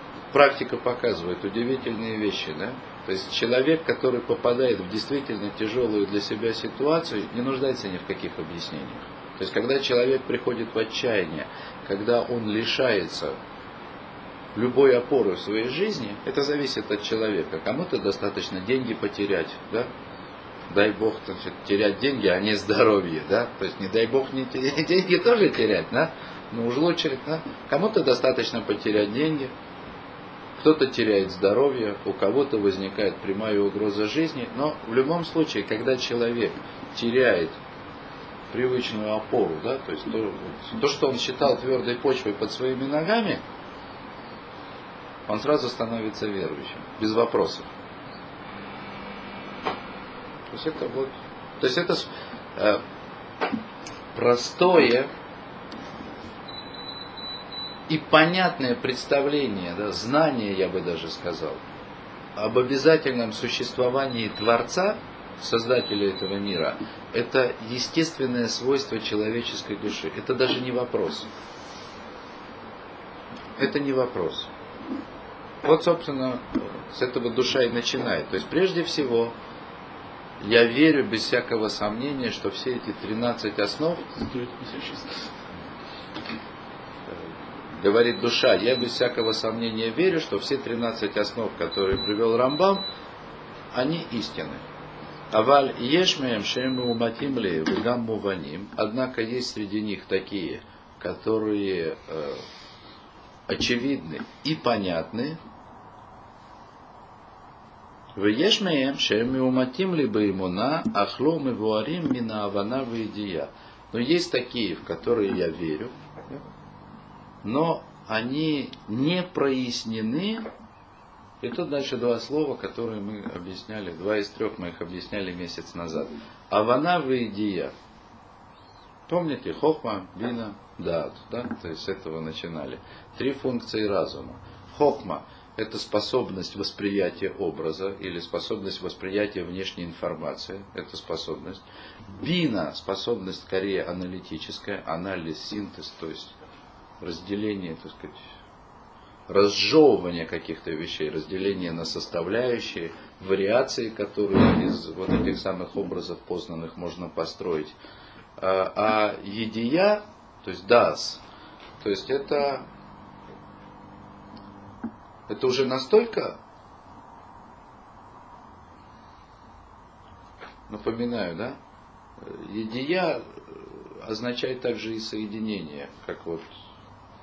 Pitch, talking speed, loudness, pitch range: 115 Hz, 105 wpm, -26 LUFS, 100-130 Hz